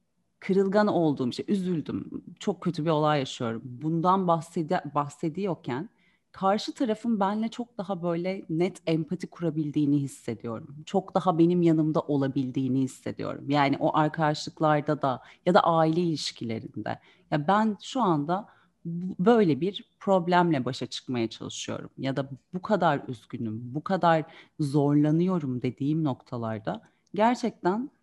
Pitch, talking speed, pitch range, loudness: 160 Hz, 125 wpm, 140-185 Hz, -27 LUFS